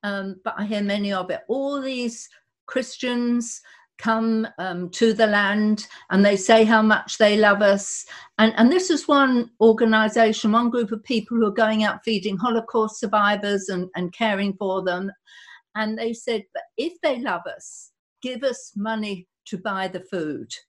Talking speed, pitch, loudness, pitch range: 175 wpm, 220 Hz, -22 LUFS, 205-235 Hz